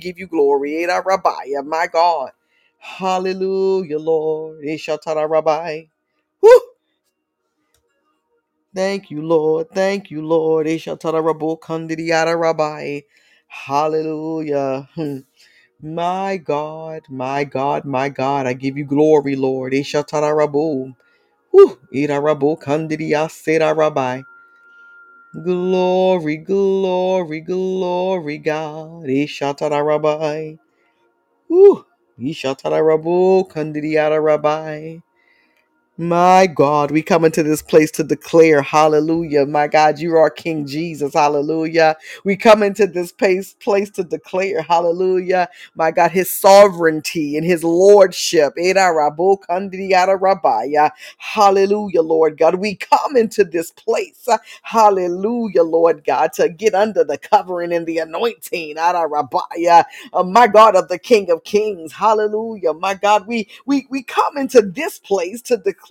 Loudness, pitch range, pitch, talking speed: -16 LUFS, 155-195 Hz, 165 Hz, 115 wpm